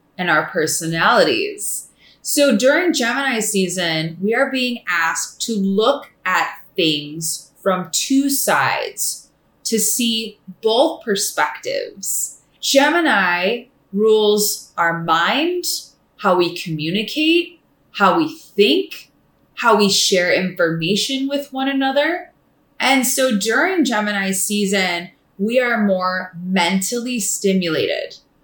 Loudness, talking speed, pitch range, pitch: -18 LUFS, 105 wpm, 185-270 Hz, 215 Hz